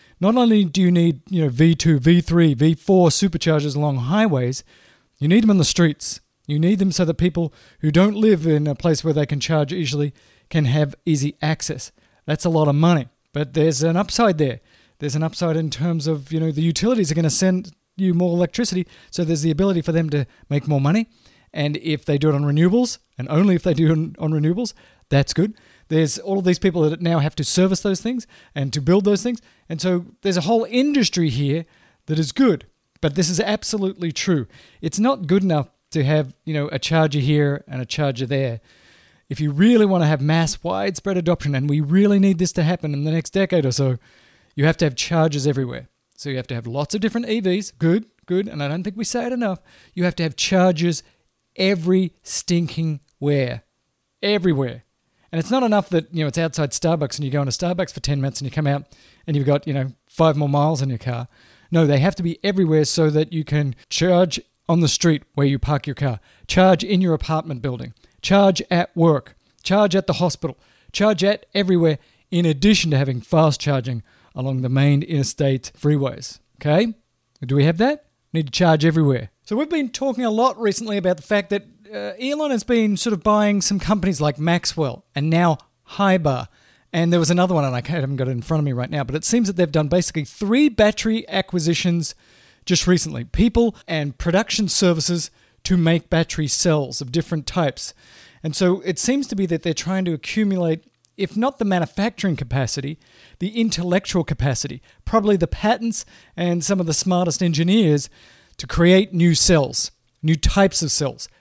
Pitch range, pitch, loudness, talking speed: 145-190 Hz, 165 Hz, -20 LUFS, 210 wpm